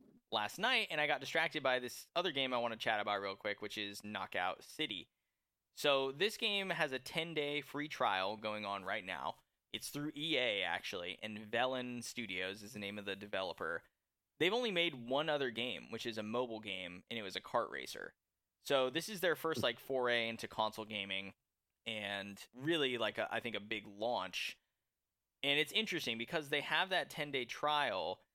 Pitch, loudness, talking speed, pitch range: 125 Hz, -38 LUFS, 195 wpm, 105-150 Hz